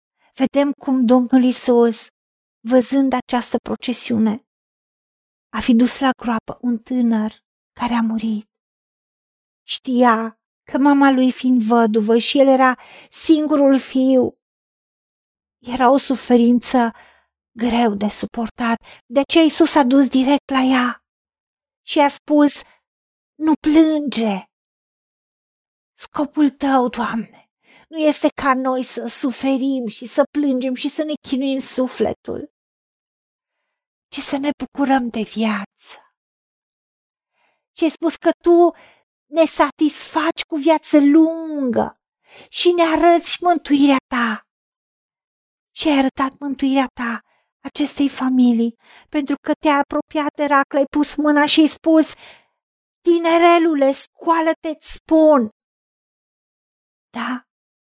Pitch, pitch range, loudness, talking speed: 270 Hz, 245-300 Hz, -17 LUFS, 110 wpm